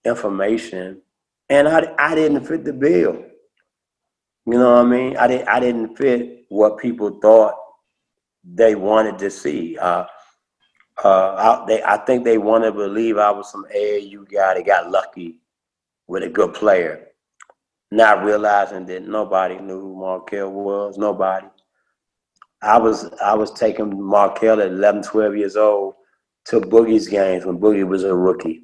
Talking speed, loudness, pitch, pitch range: 155 wpm, -17 LUFS, 105 Hz, 95-115 Hz